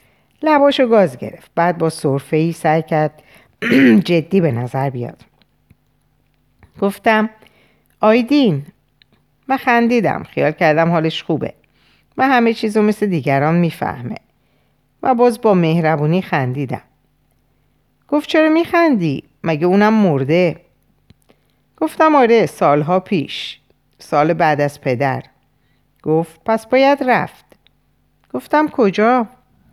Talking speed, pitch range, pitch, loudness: 105 wpm, 155-240 Hz, 185 Hz, -15 LUFS